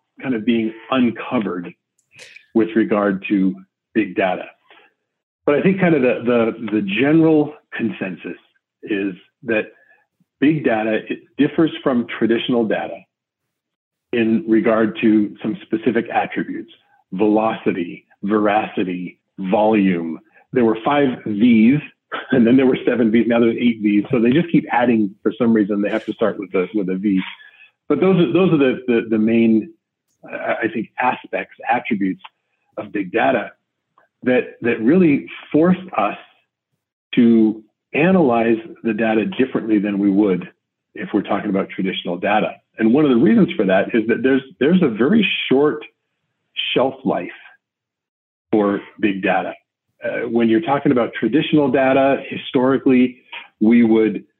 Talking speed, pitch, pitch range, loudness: 145 wpm, 115 Hz, 110-140 Hz, -18 LUFS